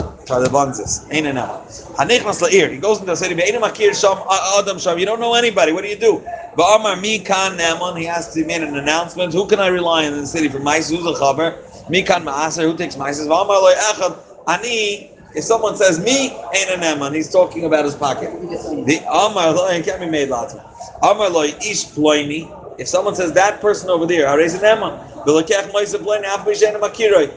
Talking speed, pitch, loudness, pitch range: 205 wpm, 180 Hz, -16 LUFS, 155-205 Hz